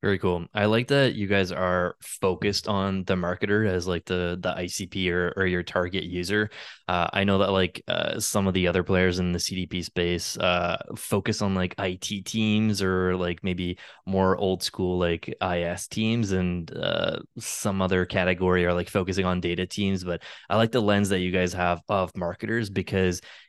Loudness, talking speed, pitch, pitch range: -26 LUFS, 190 wpm, 95 Hz, 90-100 Hz